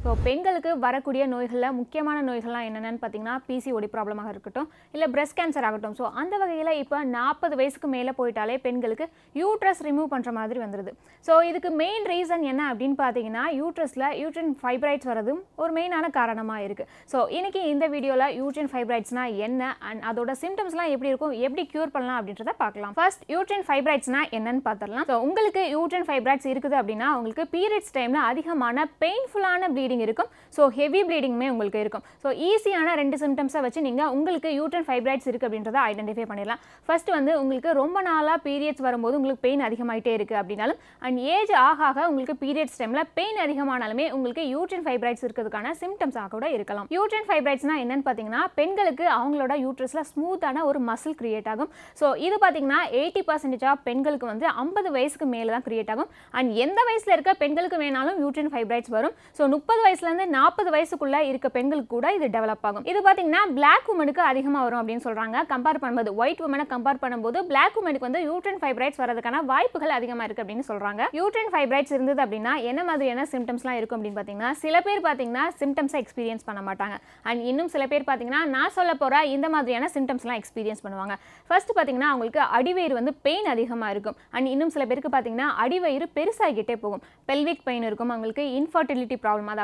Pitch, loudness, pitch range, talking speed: 275 Hz, -25 LUFS, 245-320 Hz, 165 wpm